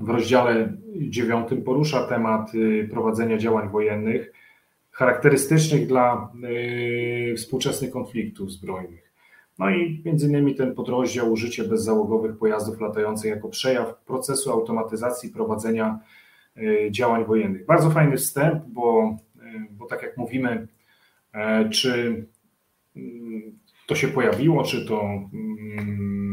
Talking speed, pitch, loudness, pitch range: 100 wpm, 115 Hz, -23 LUFS, 110-130 Hz